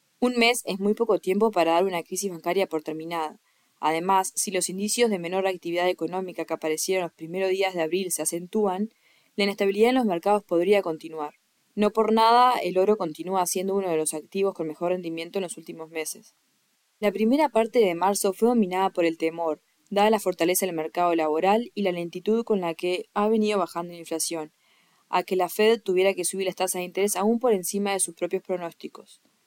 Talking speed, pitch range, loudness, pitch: 205 wpm, 170-205 Hz, -25 LUFS, 185 Hz